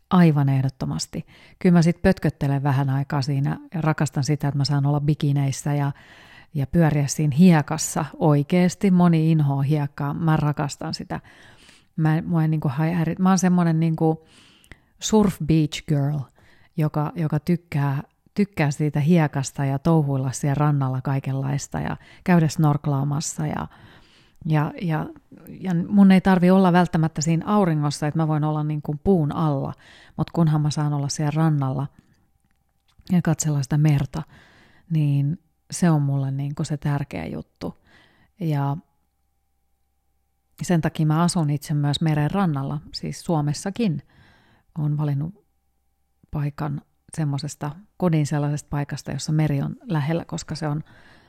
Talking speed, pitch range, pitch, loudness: 140 wpm, 140-165 Hz, 150 Hz, -22 LUFS